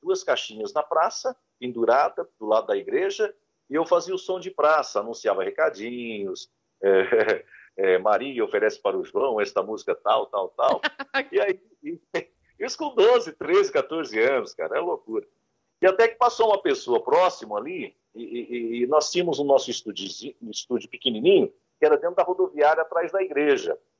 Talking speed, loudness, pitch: 175 wpm, -24 LUFS, 355 Hz